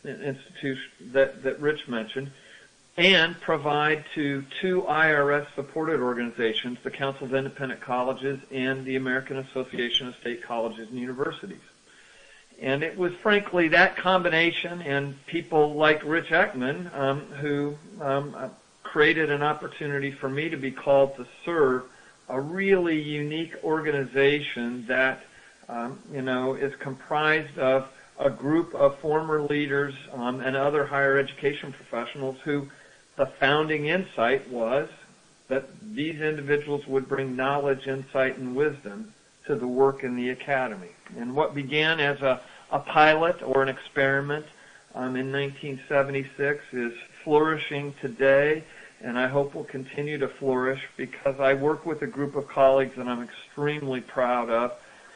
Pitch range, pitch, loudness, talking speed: 130-150 Hz, 140 Hz, -26 LUFS, 135 wpm